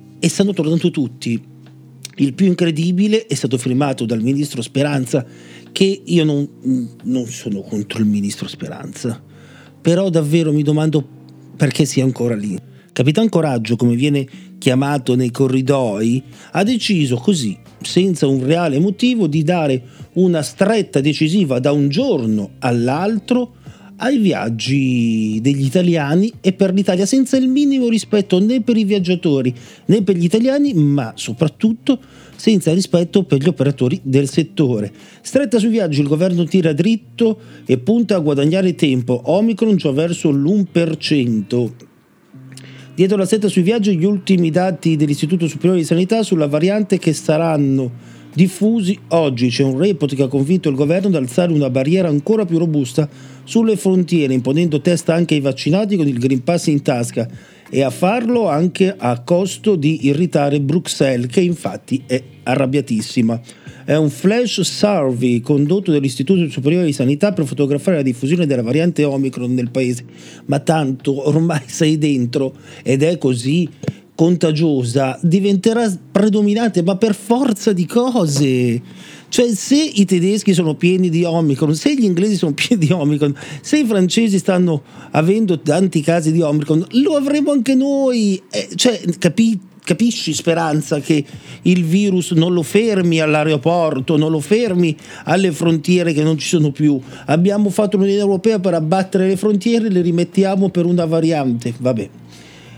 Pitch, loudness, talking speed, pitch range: 160 Hz, -16 LUFS, 150 wpm, 135-195 Hz